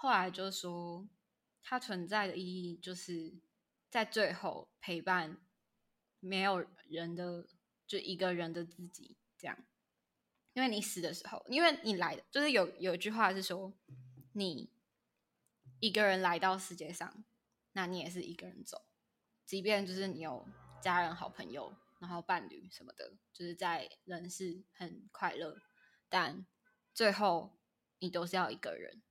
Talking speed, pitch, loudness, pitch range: 215 characters per minute, 185 Hz, -37 LUFS, 175-205 Hz